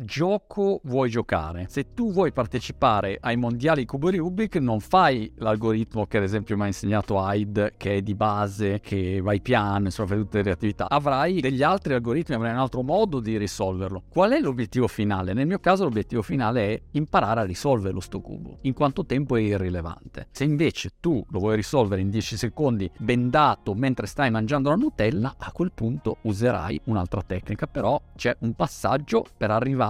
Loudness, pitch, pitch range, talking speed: -25 LUFS, 115 Hz, 105-135 Hz, 185 wpm